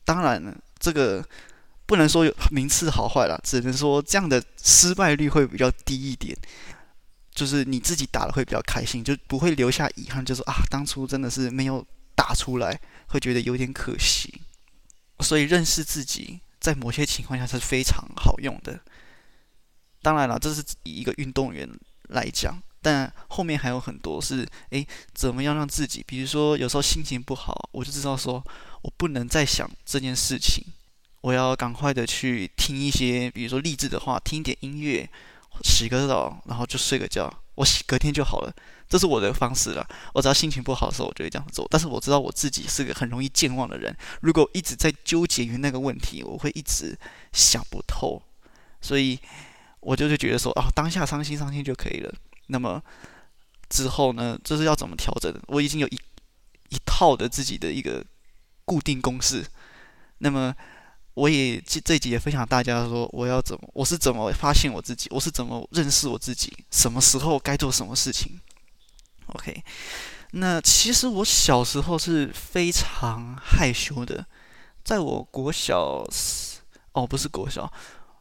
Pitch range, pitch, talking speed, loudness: 125-150 Hz, 135 Hz, 270 characters per minute, -24 LUFS